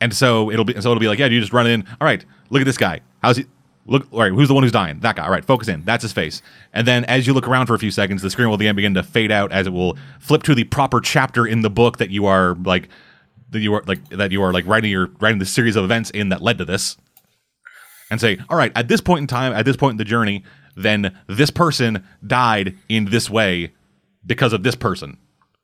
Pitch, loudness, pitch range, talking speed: 115 Hz, -18 LUFS, 100-125 Hz, 275 wpm